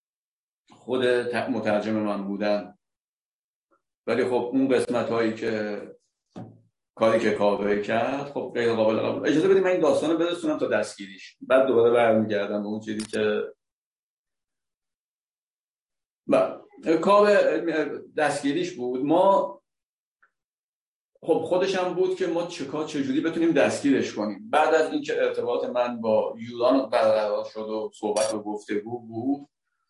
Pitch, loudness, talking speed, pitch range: 120 Hz, -24 LUFS, 130 wpm, 110-160 Hz